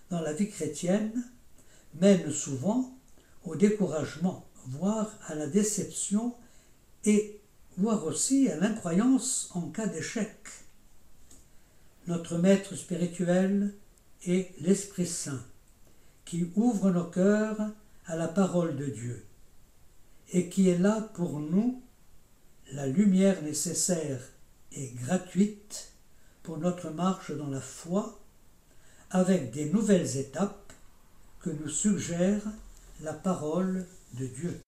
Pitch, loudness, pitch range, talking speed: 180 Hz, -29 LUFS, 150-205 Hz, 105 wpm